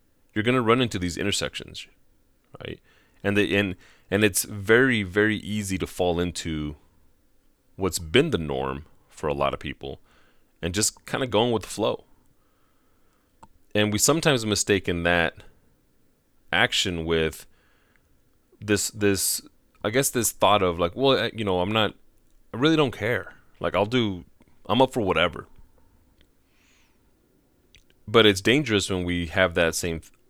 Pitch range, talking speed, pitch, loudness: 85-105 Hz, 150 wpm, 95 Hz, -24 LUFS